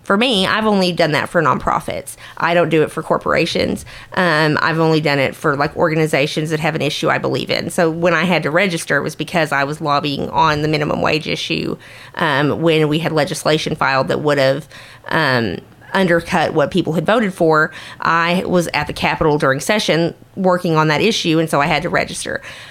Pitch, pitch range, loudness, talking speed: 160 Hz, 150-175 Hz, -16 LUFS, 210 wpm